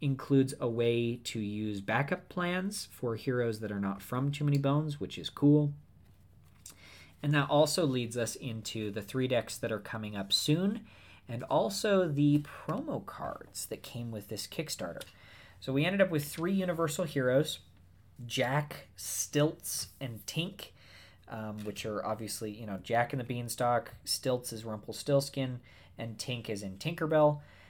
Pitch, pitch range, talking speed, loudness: 120 Hz, 105-145 Hz, 160 wpm, -33 LUFS